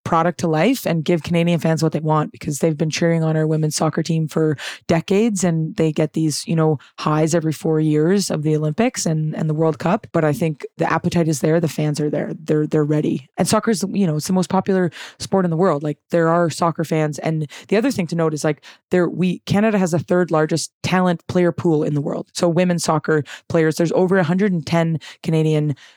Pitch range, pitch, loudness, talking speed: 155-180 Hz, 165 Hz, -19 LUFS, 230 wpm